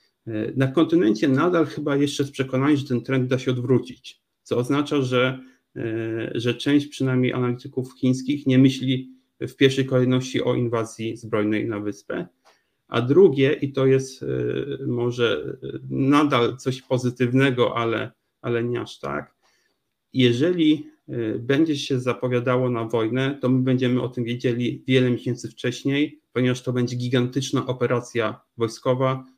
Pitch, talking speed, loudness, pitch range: 130 Hz, 135 wpm, -23 LUFS, 120-135 Hz